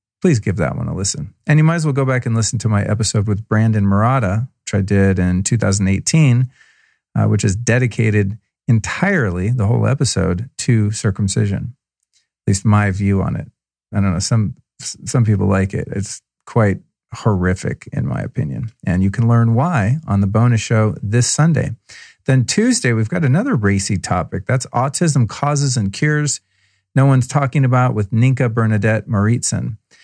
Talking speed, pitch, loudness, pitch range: 175 wpm, 115 Hz, -17 LUFS, 100-130 Hz